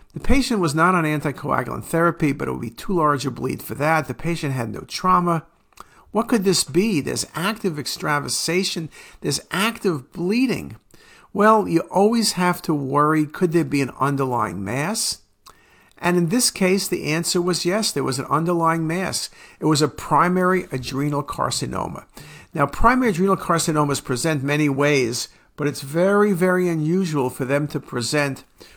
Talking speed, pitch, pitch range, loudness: 165 wpm, 165 Hz, 145-185 Hz, -21 LUFS